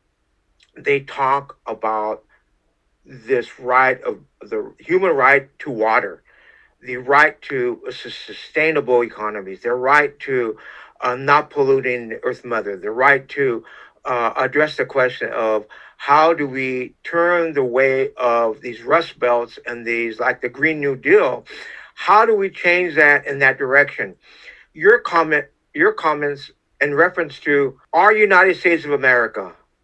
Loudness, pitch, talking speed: -17 LUFS, 150 Hz, 140 wpm